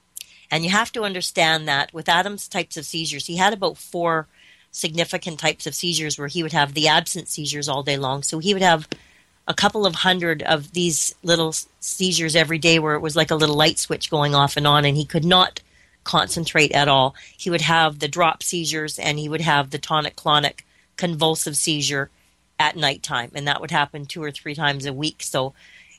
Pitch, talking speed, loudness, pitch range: 155 Hz, 210 wpm, -20 LUFS, 145-170 Hz